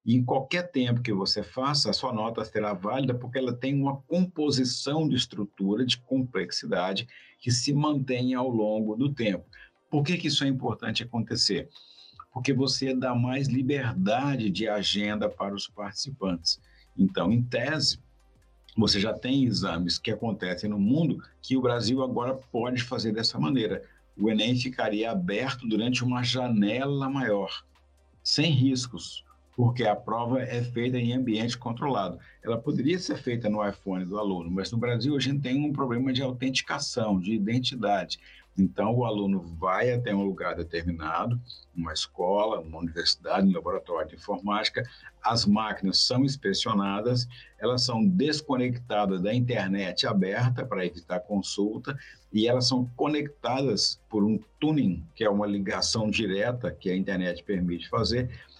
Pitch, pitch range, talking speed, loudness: 120 Hz, 100-130 Hz, 150 wpm, -27 LUFS